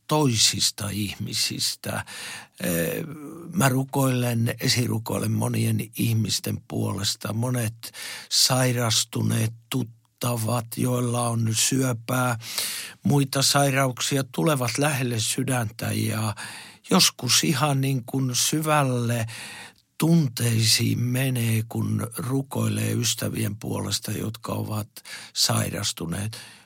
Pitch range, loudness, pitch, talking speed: 110-130 Hz, -24 LUFS, 120 Hz, 75 wpm